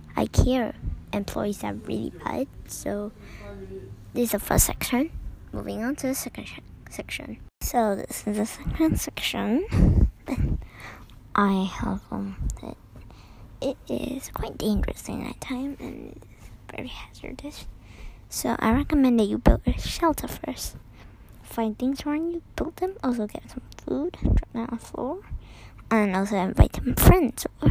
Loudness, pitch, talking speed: -26 LUFS, 220 Hz, 150 wpm